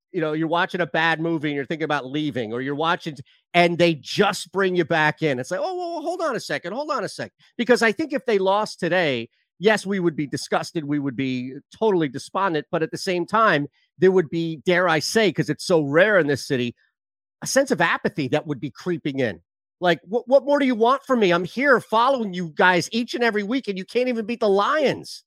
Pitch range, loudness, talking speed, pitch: 150-220 Hz, -22 LUFS, 250 wpm, 175 Hz